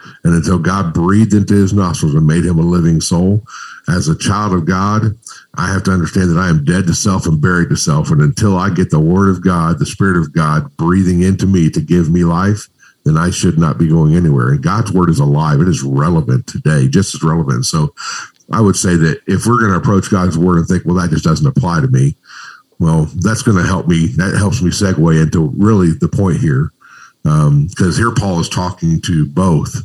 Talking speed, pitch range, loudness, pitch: 230 wpm, 85-100 Hz, -13 LUFS, 90 Hz